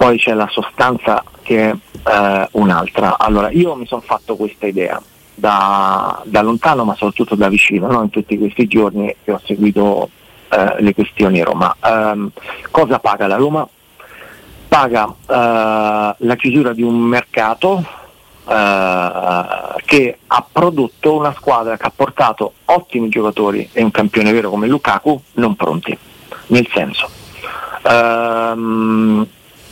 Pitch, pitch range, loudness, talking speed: 110 Hz, 105-120 Hz, -14 LUFS, 140 wpm